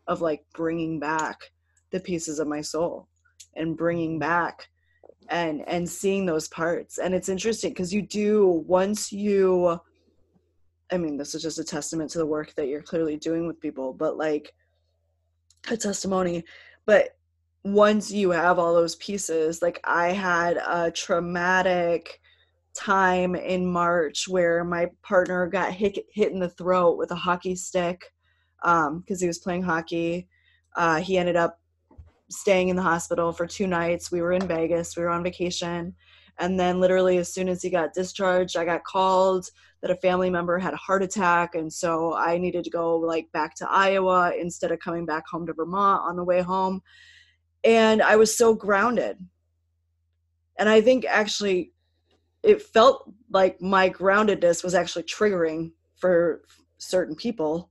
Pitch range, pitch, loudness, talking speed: 160-185 Hz, 175 Hz, -24 LUFS, 165 wpm